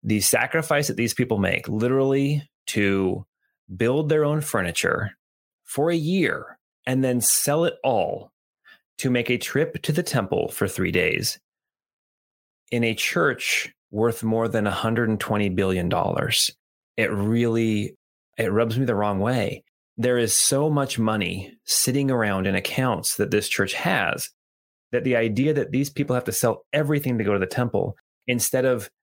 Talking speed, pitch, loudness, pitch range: 165 wpm, 120 Hz, -23 LUFS, 105-135 Hz